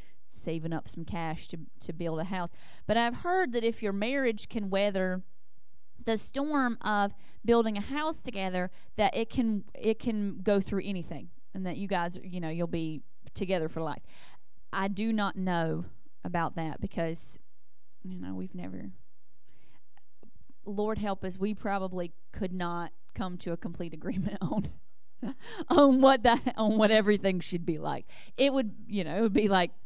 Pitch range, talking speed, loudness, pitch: 170-220 Hz, 170 wpm, -31 LUFS, 195 Hz